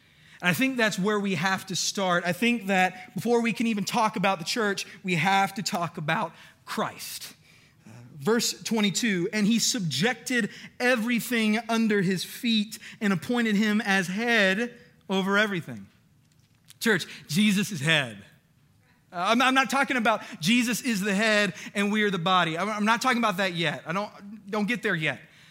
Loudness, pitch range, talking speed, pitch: -25 LUFS, 180-225 Hz, 175 wpm, 205 Hz